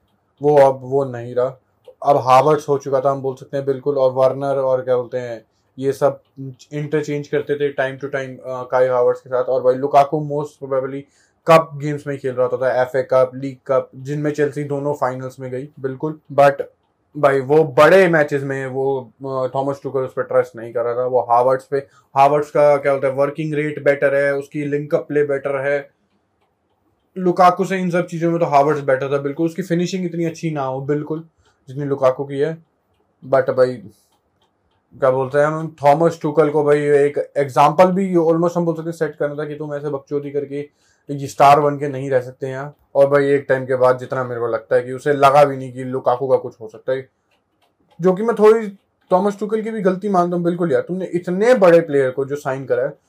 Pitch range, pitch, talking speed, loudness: 130-150 Hz, 140 Hz, 215 wpm, -18 LUFS